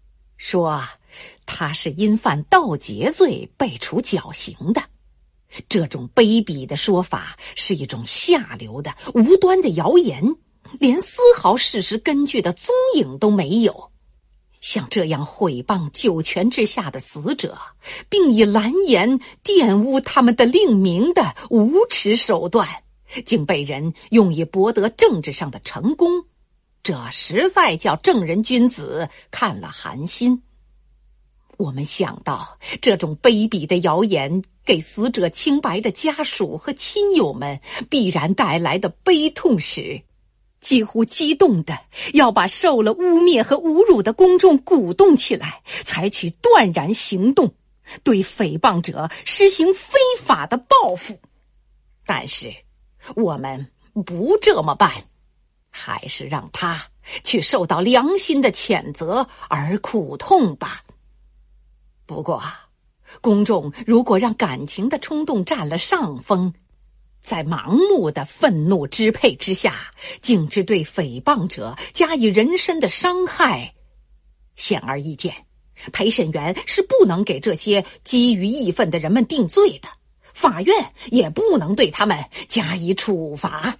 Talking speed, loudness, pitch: 190 characters per minute, -18 LUFS, 215 Hz